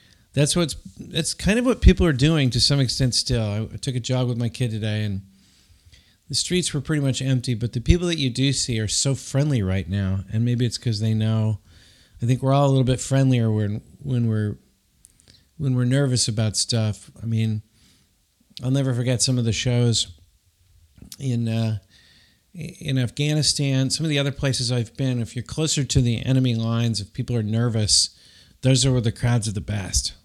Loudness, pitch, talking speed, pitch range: -22 LUFS, 120 Hz, 200 wpm, 110-135 Hz